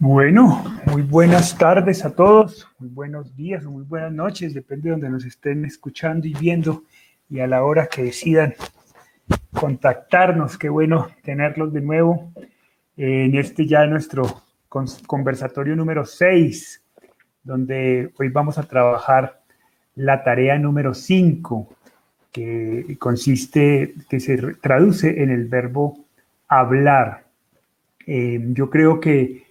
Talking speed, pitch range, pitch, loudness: 125 wpm, 130-160 Hz, 145 Hz, -18 LUFS